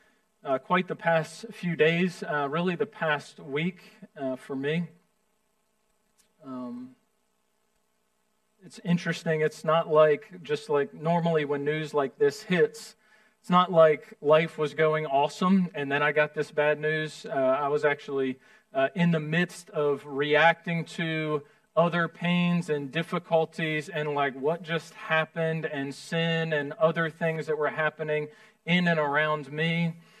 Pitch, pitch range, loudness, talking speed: 165 Hz, 150-215 Hz, -27 LUFS, 145 wpm